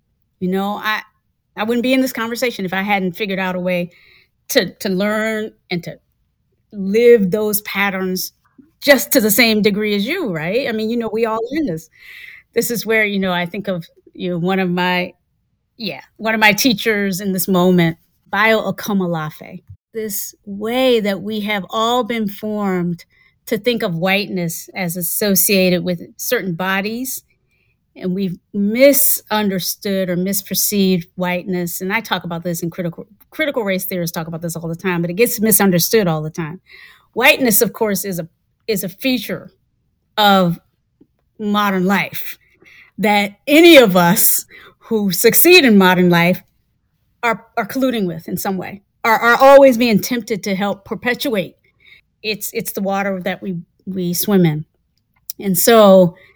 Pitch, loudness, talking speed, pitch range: 200 Hz, -16 LUFS, 165 wpm, 180-225 Hz